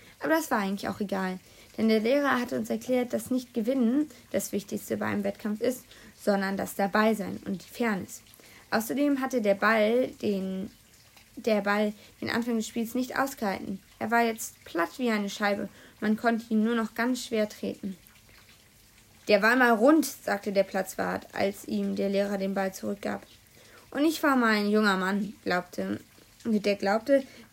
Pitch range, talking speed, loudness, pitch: 195-240 Hz, 170 wpm, -28 LUFS, 215 Hz